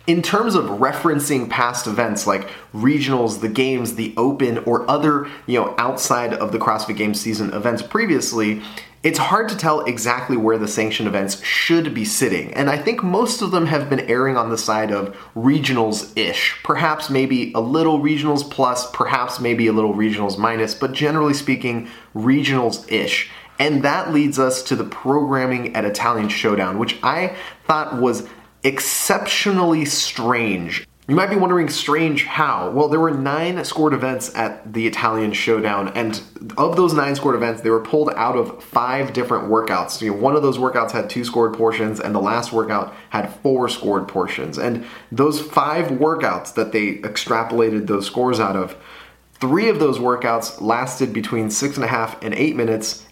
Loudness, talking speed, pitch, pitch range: -19 LUFS, 175 wpm, 125 Hz, 110-145 Hz